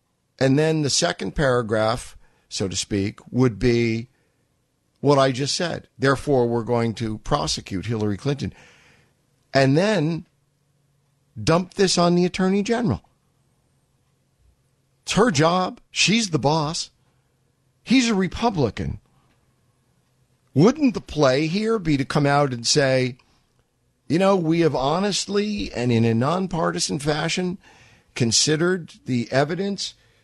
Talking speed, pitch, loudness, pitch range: 120 wpm, 140 Hz, -21 LUFS, 125-175 Hz